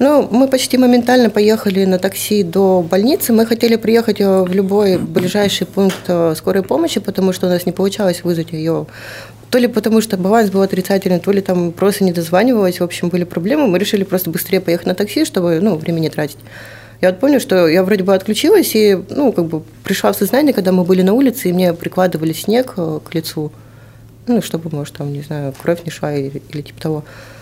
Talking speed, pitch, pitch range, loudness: 205 wpm, 190 Hz, 170-215 Hz, -15 LUFS